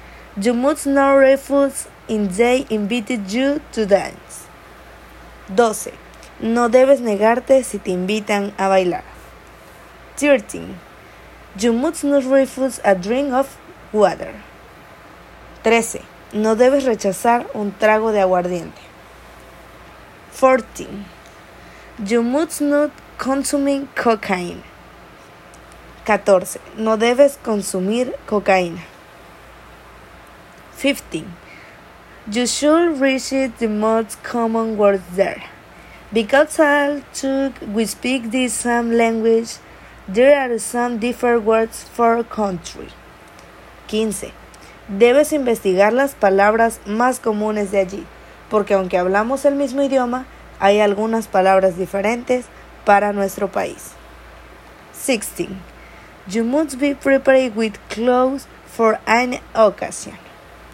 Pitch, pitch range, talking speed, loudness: 230 Hz, 205-265 Hz, 100 wpm, -18 LUFS